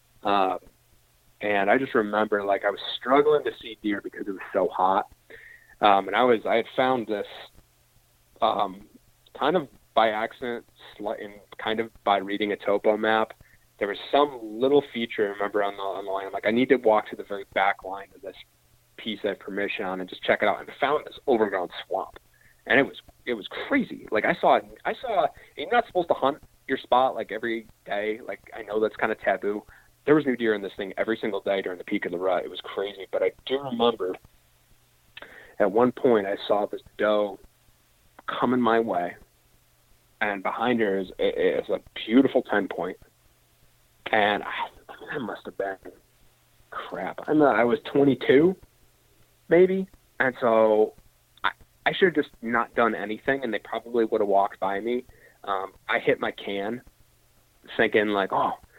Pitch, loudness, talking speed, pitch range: 115 Hz, -25 LUFS, 195 wpm, 105-130 Hz